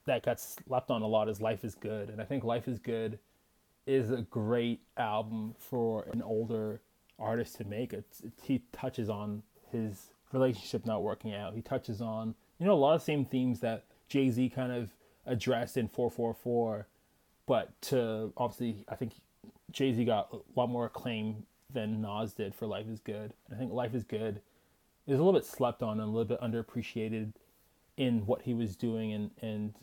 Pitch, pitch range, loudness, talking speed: 115 Hz, 110-125 Hz, -34 LUFS, 195 wpm